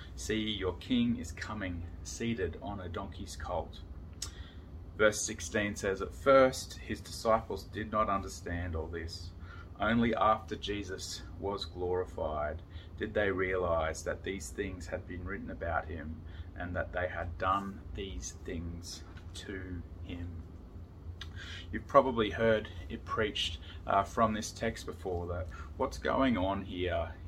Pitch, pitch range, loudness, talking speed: 90 Hz, 85-100 Hz, -34 LUFS, 135 wpm